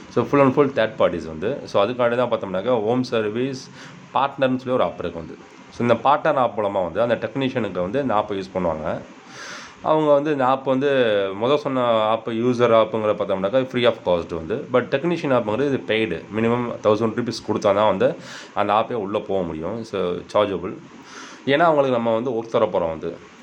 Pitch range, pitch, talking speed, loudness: 110-135 Hz, 120 Hz, 180 wpm, -21 LUFS